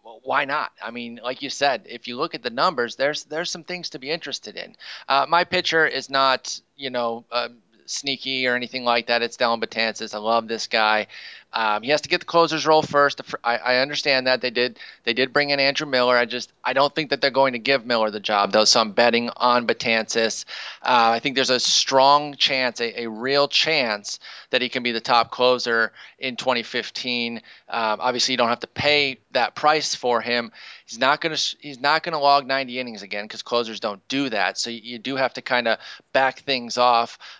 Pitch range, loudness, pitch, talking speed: 120-140 Hz, -21 LUFS, 125 Hz, 225 wpm